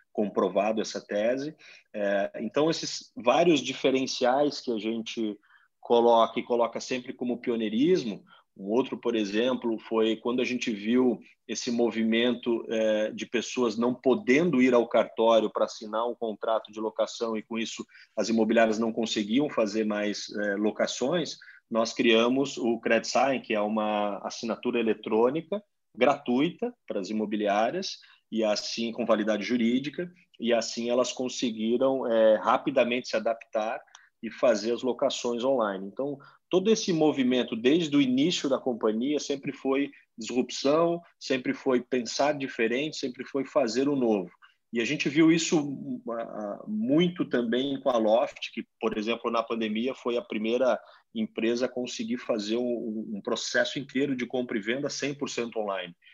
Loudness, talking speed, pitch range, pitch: -27 LUFS, 140 wpm, 110-135 Hz, 120 Hz